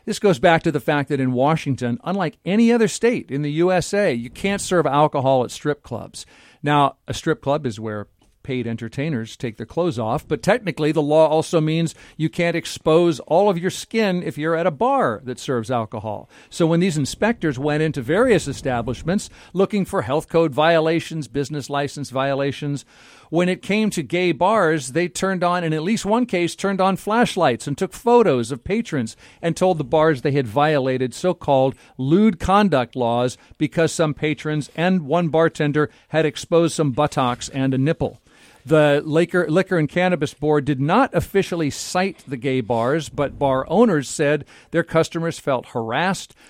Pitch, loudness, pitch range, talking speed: 155 Hz, -20 LUFS, 135-175 Hz, 180 wpm